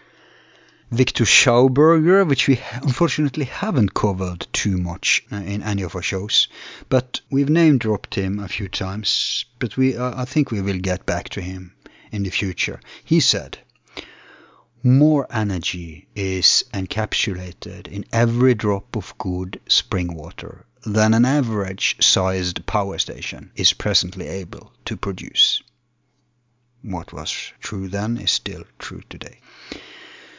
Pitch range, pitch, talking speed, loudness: 95-125 Hz, 105 Hz, 135 wpm, -20 LUFS